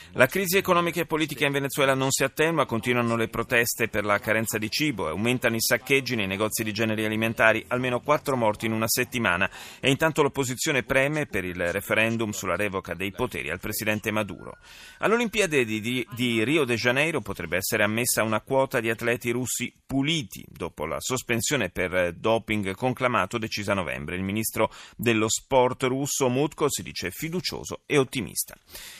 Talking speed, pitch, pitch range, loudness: 170 wpm, 115 Hz, 110-135 Hz, -25 LUFS